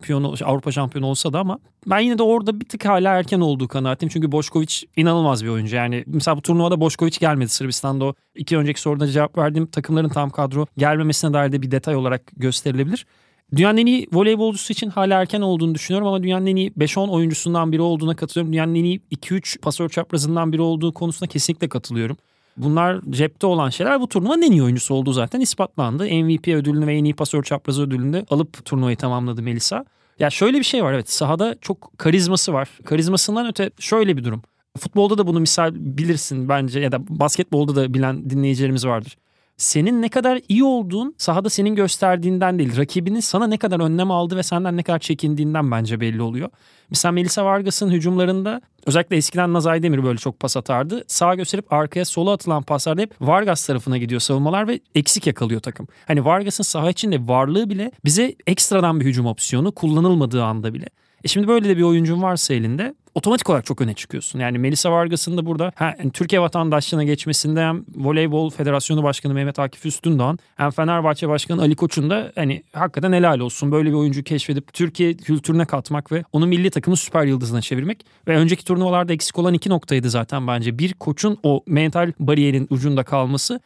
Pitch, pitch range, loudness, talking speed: 160 Hz, 140-180 Hz, -19 LUFS, 185 wpm